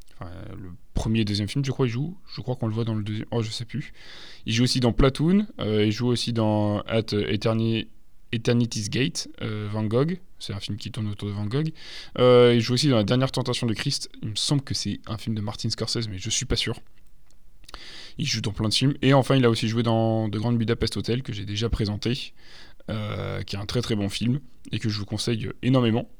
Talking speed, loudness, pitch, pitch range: 245 wpm, -25 LUFS, 115 Hz, 105-125 Hz